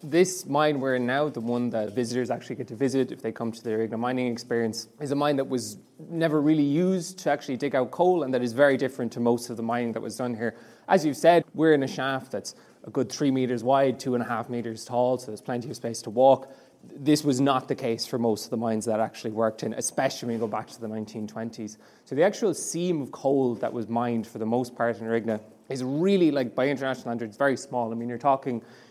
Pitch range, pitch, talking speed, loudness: 115-140 Hz, 125 Hz, 255 wpm, -26 LUFS